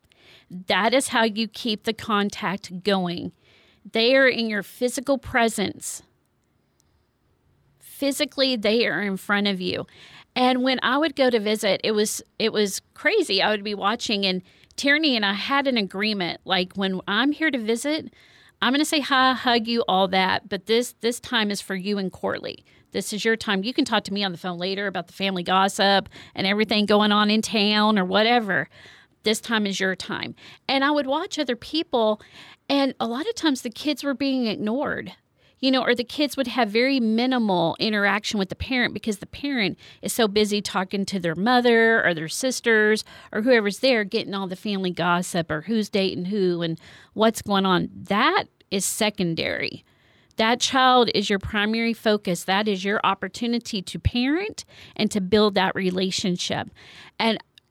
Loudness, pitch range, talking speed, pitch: -23 LUFS, 195-245 Hz, 185 wpm, 215 Hz